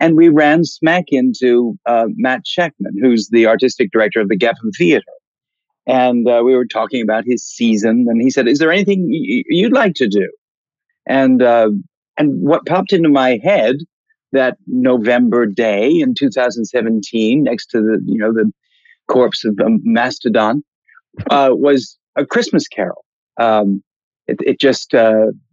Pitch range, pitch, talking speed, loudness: 115-180 Hz, 125 Hz, 160 wpm, -14 LUFS